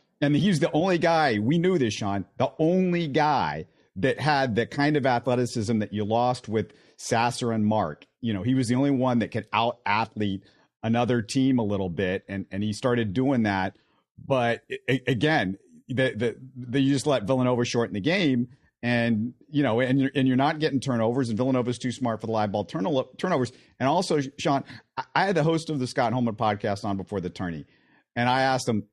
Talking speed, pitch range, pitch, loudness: 210 wpm, 110-135 Hz, 125 Hz, -25 LUFS